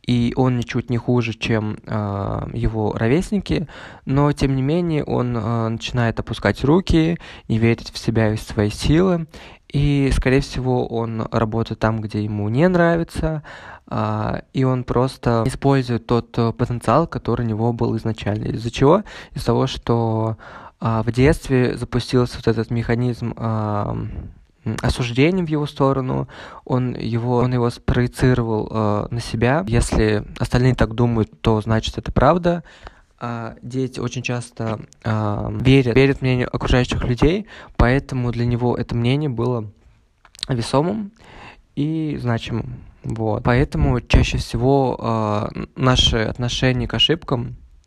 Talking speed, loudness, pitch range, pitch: 135 wpm, -20 LUFS, 110-130 Hz, 120 Hz